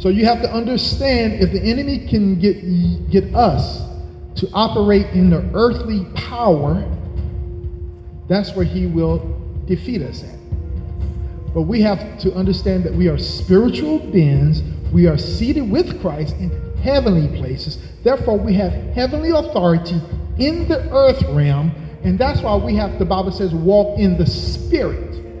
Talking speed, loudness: 150 wpm, -17 LUFS